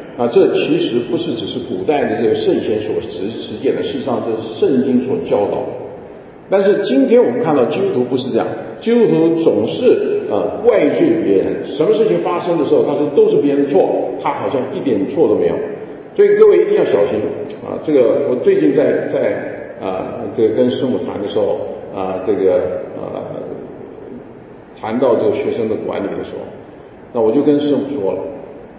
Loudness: -15 LUFS